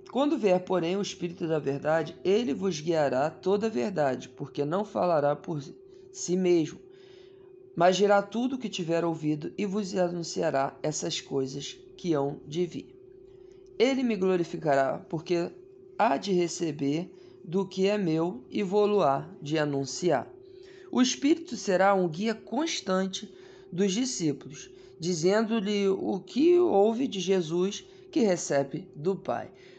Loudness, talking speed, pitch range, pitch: -28 LUFS, 140 wpm, 170-265 Hz, 195 Hz